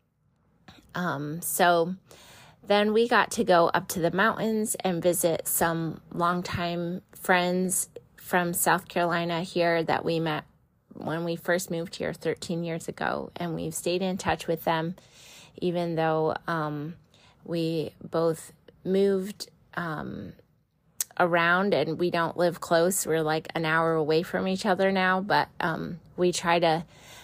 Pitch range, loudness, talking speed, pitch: 165-185 Hz, -27 LUFS, 145 wpm, 170 Hz